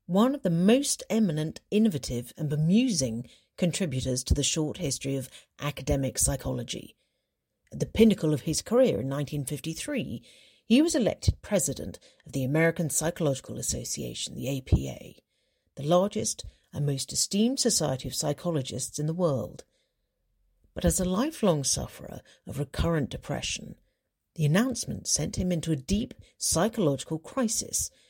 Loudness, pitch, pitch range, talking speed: -28 LUFS, 155 Hz, 135-200 Hz, 135 wpm